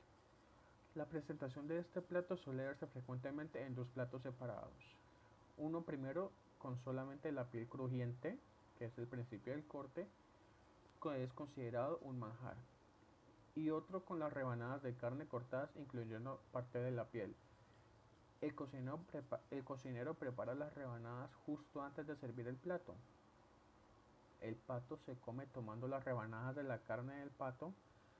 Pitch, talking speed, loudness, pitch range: 130 Hz, 145 wpm, -49 LUFS, 115-145 Hz